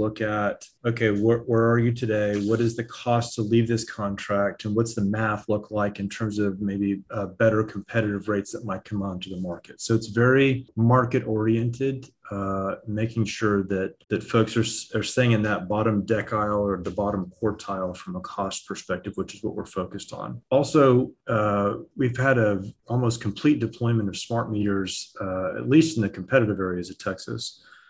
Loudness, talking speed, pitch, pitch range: -25 LUFS, 190 wpm, 105 Hz, 100-115 Hz